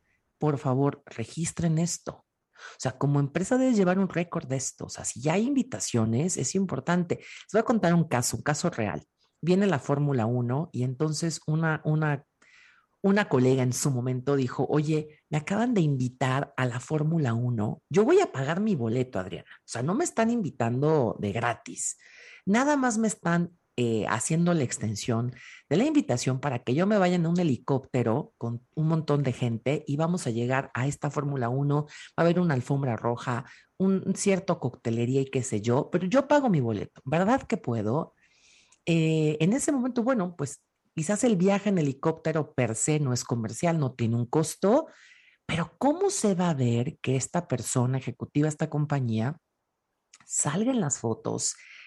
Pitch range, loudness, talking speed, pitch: 125-180 Hz, -27 LUFS, 185 wpm, 150 Hz